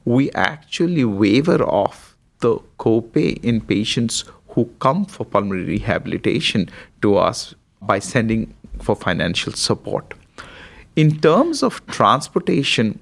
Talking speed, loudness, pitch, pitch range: 110 wpm, -19 LUFS, 120 Hz, 110-150 Hz